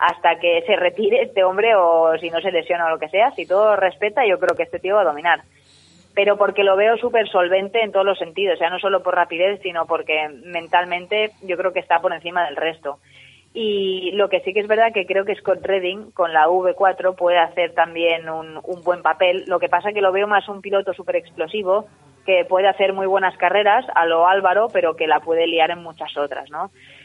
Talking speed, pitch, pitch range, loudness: 235 wpm, 180 Hz, 170-195 Hz, -19 LUFS